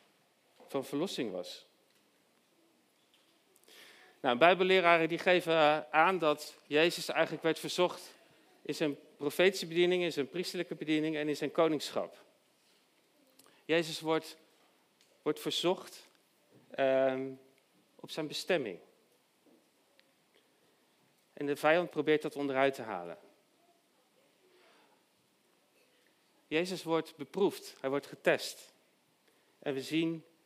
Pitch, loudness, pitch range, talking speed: 160 Hz, -32 LUFS, 150-175 Hz, 100 wpm